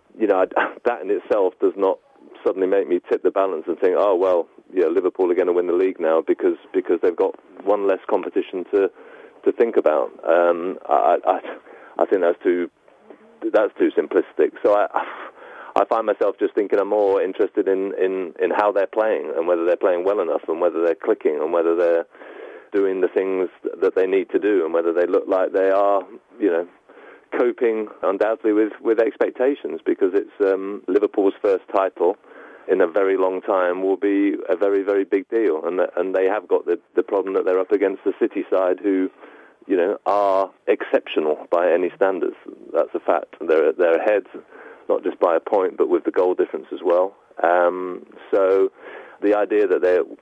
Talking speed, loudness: 195 wpm, -20 LUFS